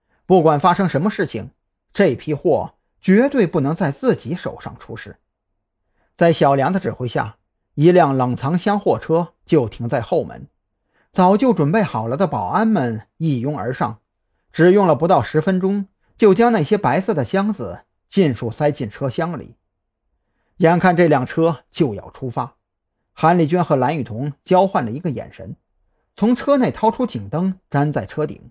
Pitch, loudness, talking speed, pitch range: 160 Hz, -18 LUFS, 240 characters per minute, 125-185 Hz